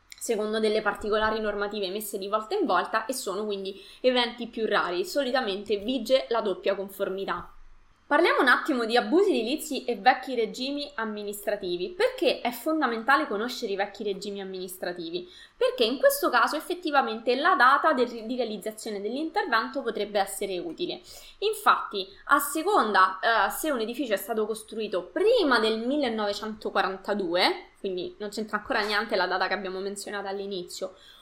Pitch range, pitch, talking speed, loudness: 205-280 Hz, 225 Hz, 145 wpm, -27 LUFS